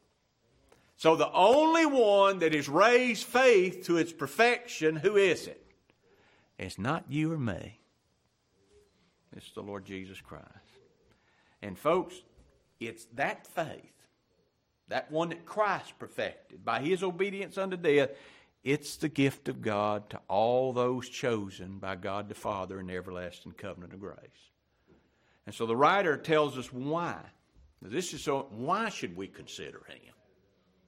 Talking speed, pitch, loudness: 145 wpm, 145 Hz, -29 LUFS